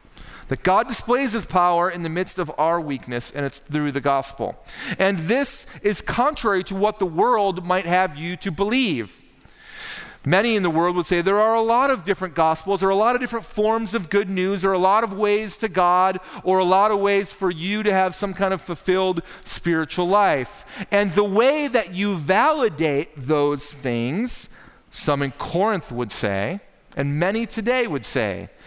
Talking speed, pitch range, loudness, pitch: 195 wpm, 170-215 Hz, -21 LUFS, 190 Hz